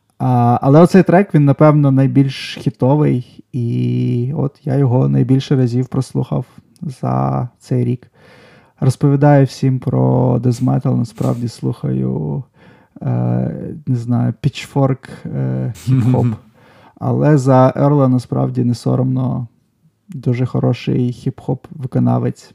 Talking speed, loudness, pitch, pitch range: 105 wpm, -15 LUFS, 125 Hz, 120-140 Hz